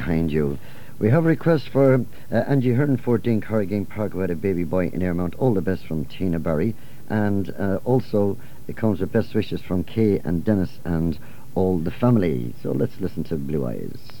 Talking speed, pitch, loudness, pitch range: 200 wpm, 100 Hz, -23 LUFS, 85-115 Hz